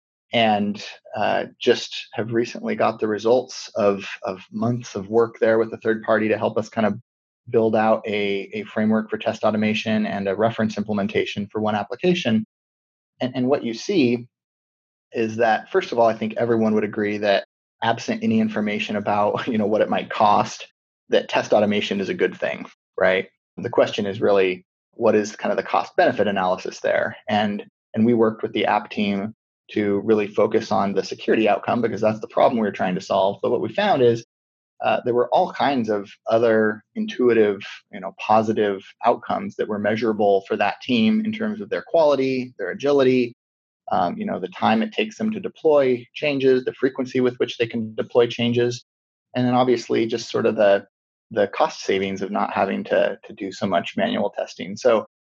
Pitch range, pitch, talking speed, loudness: 105-120 Hz, 110 Hz, 195 wpm, -21 LUFS